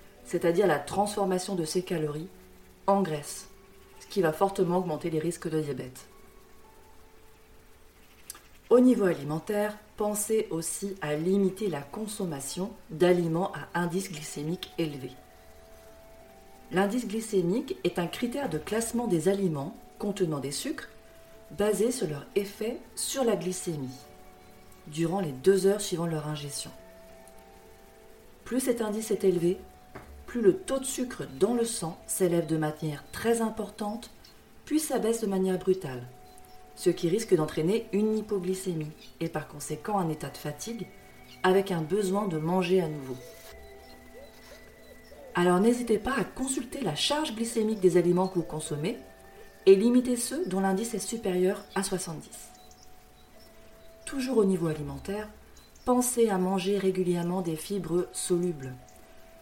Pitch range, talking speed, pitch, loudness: 150-210 Hz, 135 wpm, 185 Hz, -29 LUFS